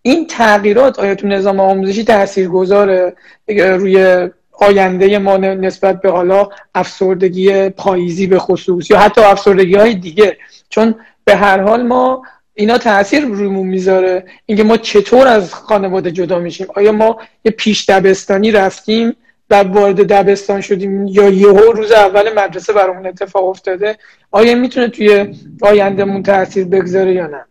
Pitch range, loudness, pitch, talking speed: 190-215 Hz, -11 LUFS, 200 Hz, 140 wpm